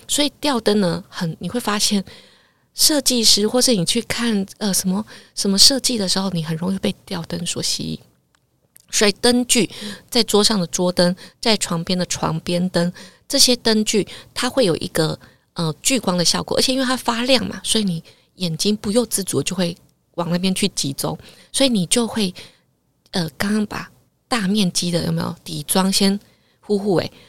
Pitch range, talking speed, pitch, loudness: 175-230 Hz, 255 characters per minute, 200 Hz, -19 LUFS